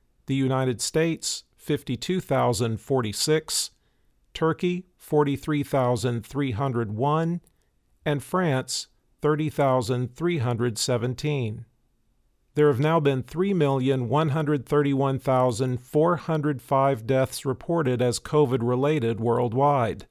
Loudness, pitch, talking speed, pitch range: -25 LUFS, 135 Hz, 60 wpm, 125-150 Hz